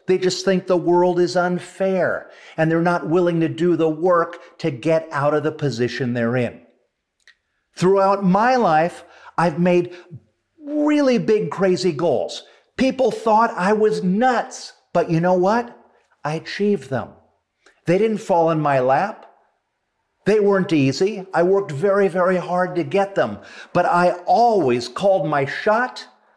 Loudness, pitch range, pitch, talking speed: -19 LUFS, 160-200 Hz, 180 Hz, 150 wpm